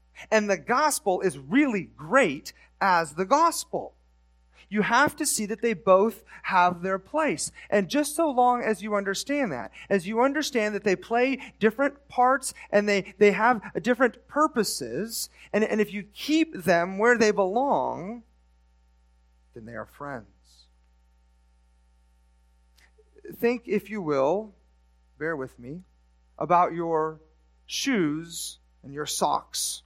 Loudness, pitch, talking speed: -25 LUFS, 200 Hz, 135 wpm